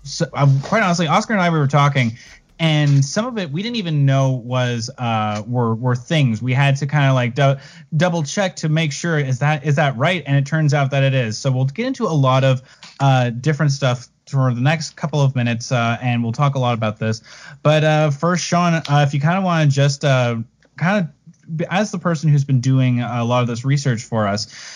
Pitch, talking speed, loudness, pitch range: 140 Hz, 240 wpm, -18 LUFS, 125-160 Hz